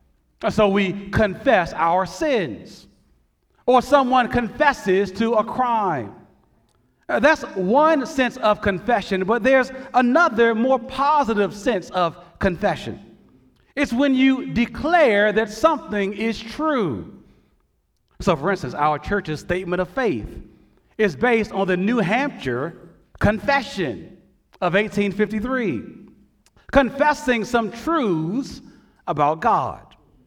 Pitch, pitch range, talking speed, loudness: 230 Hz, 200-265 Hz, 105 wpm, -20 LUFS